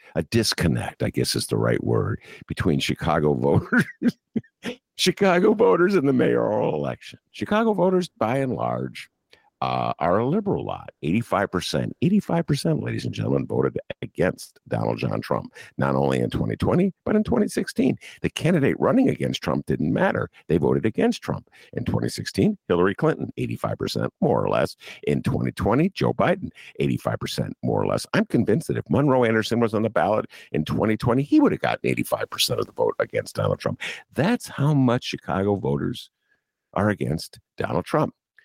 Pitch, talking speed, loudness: 135 Hz, 160 wpm, -23 LUFS